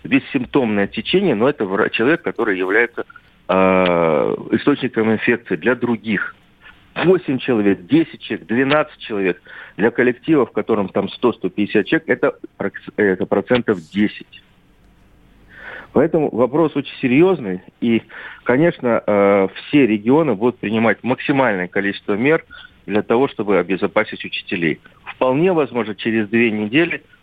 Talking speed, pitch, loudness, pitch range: 115 wpm, 110 Hz, -18 LUFS, 100-130 Hz